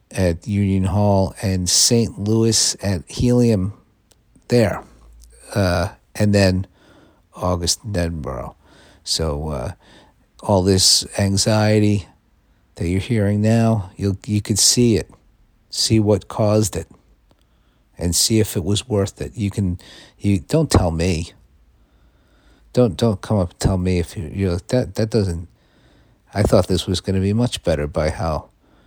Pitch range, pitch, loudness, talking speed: 85-105 Hz, 95 Hz, -19 LUFS, 150 wpm